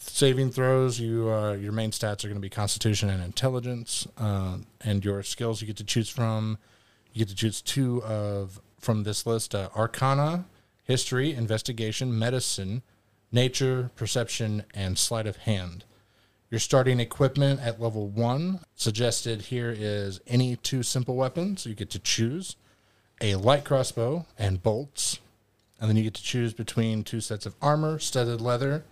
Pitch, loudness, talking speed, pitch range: 115 Hz, -28 LUFS, 165 wpm, 105-125 Hz